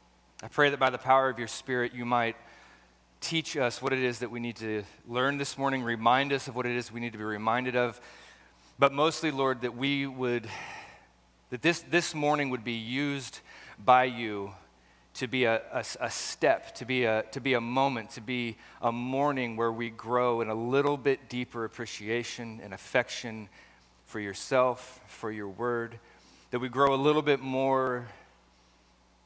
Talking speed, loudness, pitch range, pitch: 185 wpm, -29 LUFS, 110-130 Hz, 120 Hz